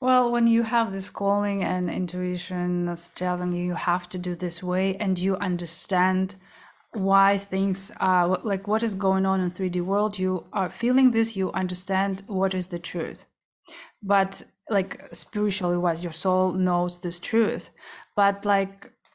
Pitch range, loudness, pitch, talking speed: 180-200 Hz, -25 LUFS, 190 Hz, 165 wpm